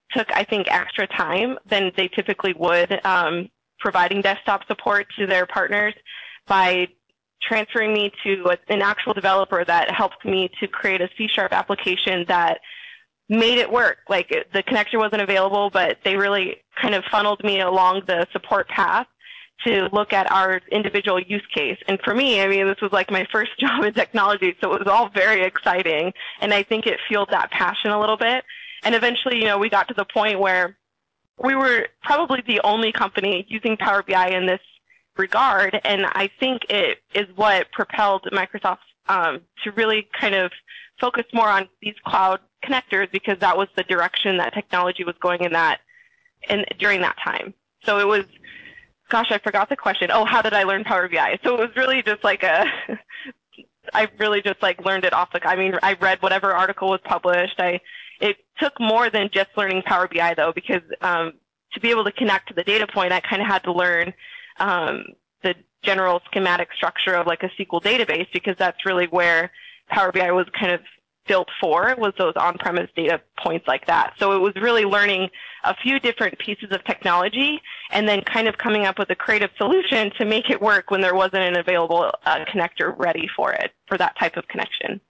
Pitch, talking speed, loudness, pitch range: 200 Hz, 195 wpm, -20 LUFS, 185-220 Hz